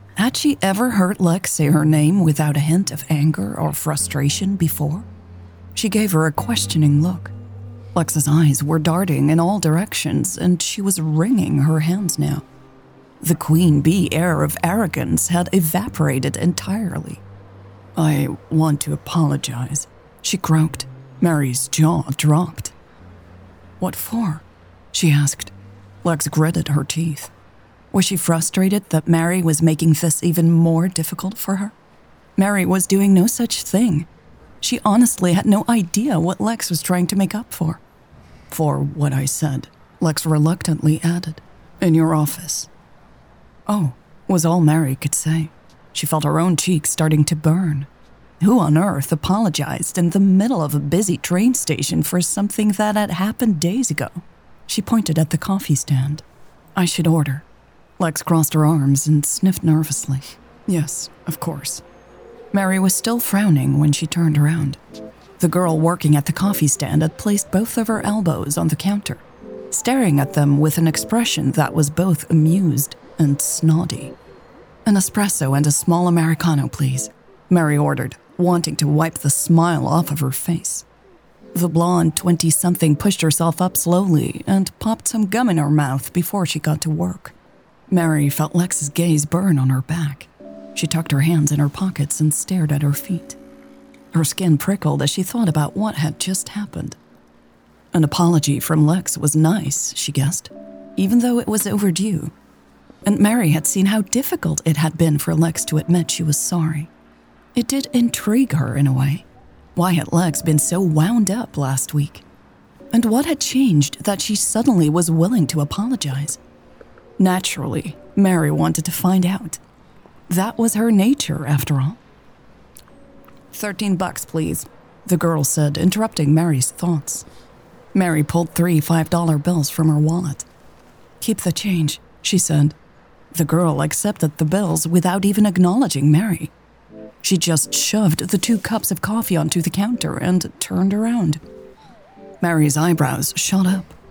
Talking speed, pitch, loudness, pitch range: 155 wpm, 165 Hz, -18 LUFS, 150-185 Hz